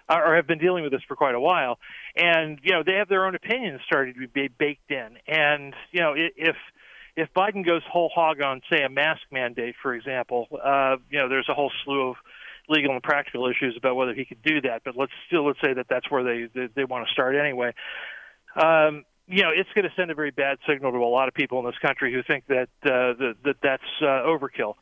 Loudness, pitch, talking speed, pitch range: -24 LUFS, 140 Hz, 240 wpm, 130-160 Hz